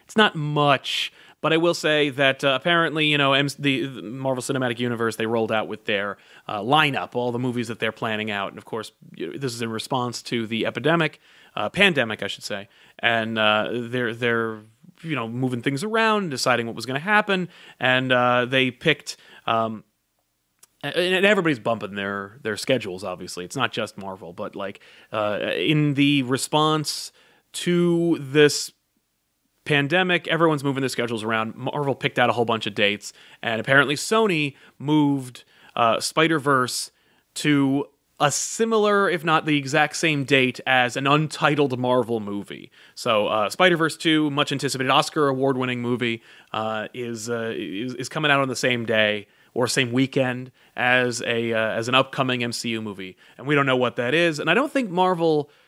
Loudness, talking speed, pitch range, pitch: -22 LUFS, 175 wpm, 115-150 Hz, 130 Hz